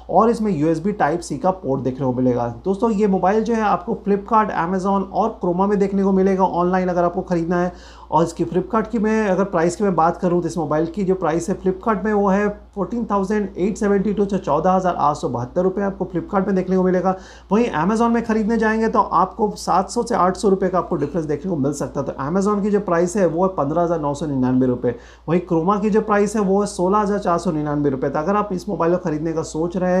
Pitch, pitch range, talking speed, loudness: 185 Hz, 165-205 Hz, 260 wpm, -19 LUFS